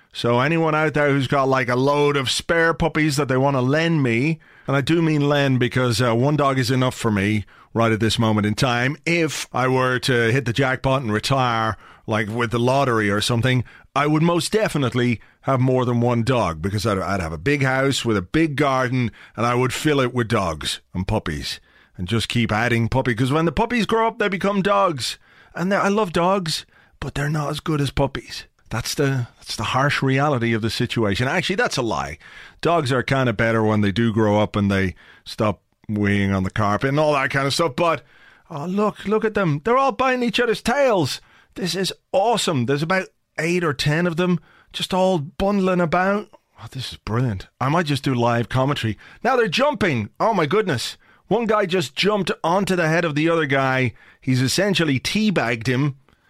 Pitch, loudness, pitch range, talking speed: 135 Hz, -20 LUFS, 120-165 Hz, 215 wpm